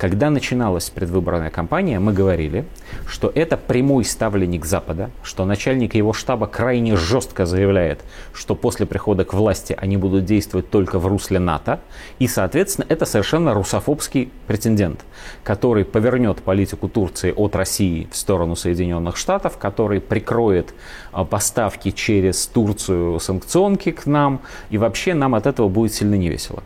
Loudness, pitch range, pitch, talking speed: -19 LUFS, 95-120 Hz, 100 Hz, 140 wpm